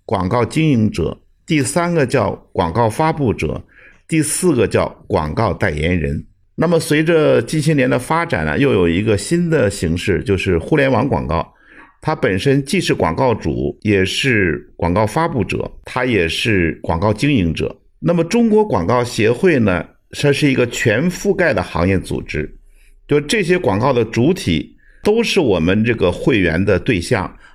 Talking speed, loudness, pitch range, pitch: 245 characters per minute, -16 LUFS, 100-160 Hz, 125 Hz